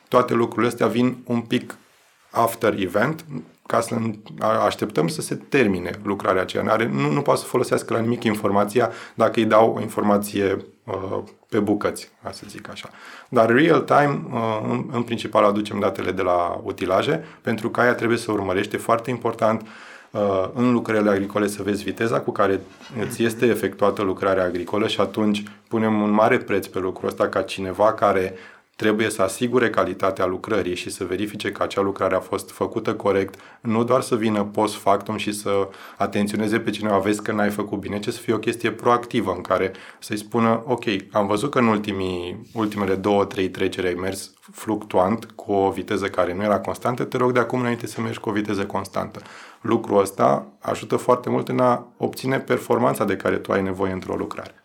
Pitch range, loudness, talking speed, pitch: 95-115 Hz, -22 LUFS, 185 wpm, 105 Hz